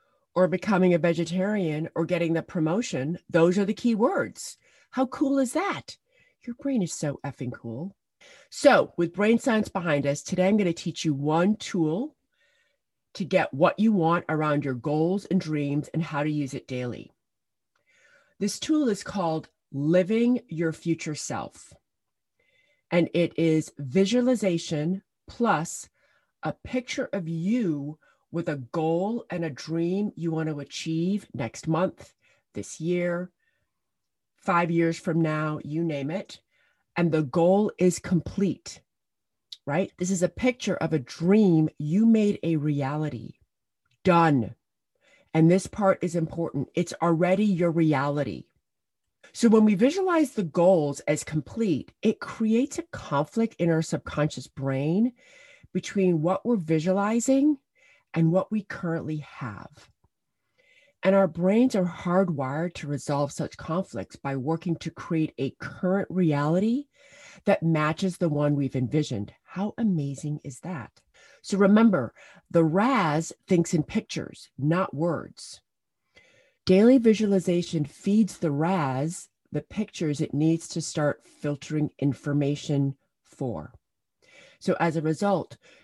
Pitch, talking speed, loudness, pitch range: 170 Hz, 135 wpm, -26 LUFS, 155-200 Hz